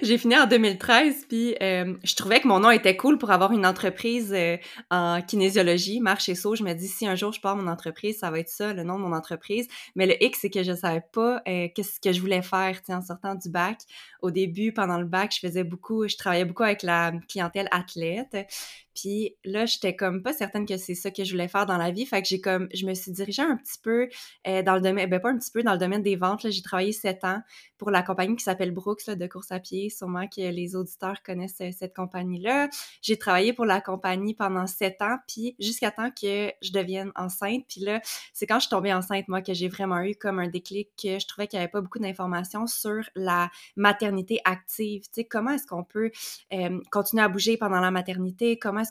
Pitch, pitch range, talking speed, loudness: 195 Hz, 185-215 Hz, 240 wpm, -26 LUFS